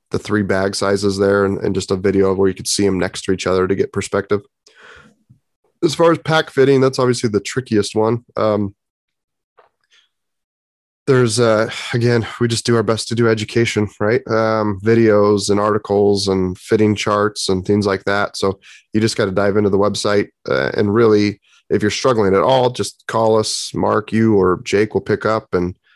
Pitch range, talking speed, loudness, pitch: 100-115 Hz, 195 wpm, -16 LUFS, 105 Hz